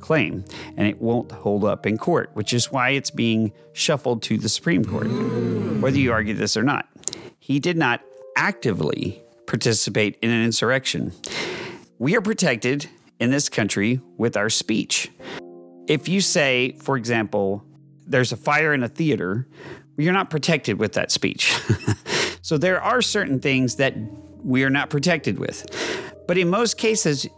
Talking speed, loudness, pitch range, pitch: 160 wpm, -21 LUFS, 115-155 Hz, 130 Hz